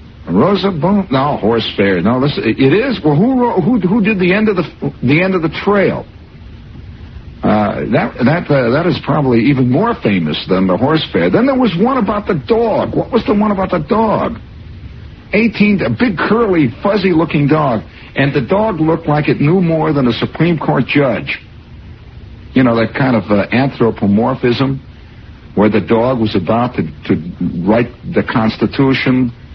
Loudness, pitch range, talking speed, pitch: -13 LUFS, 120-200 Hz, 180 wpm, 150 Hz